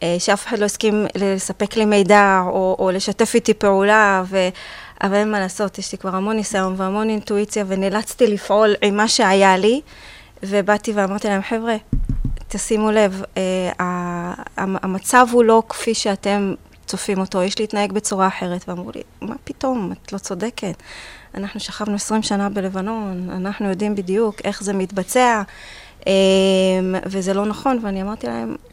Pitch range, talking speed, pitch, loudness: 190-215 Hz, 155 wpm, 200 Hz, -19 LUFS